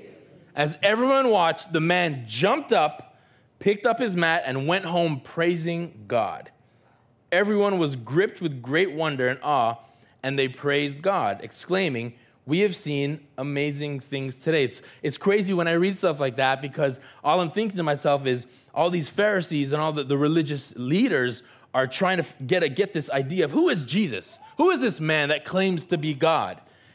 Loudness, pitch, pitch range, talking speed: -24 LUFS, 155 Hz, 135-185 Hz, 180 wpm